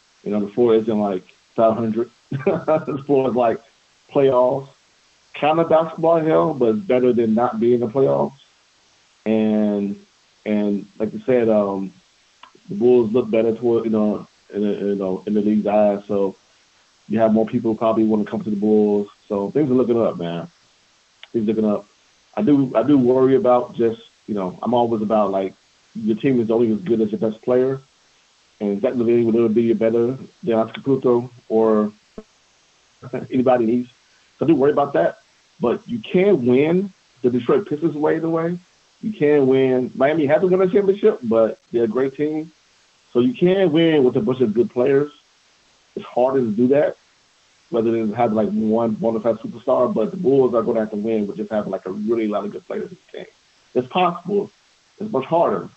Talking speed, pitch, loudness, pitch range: 195 wpm, 120 Hz, -19 LUFS, 110-135 Hz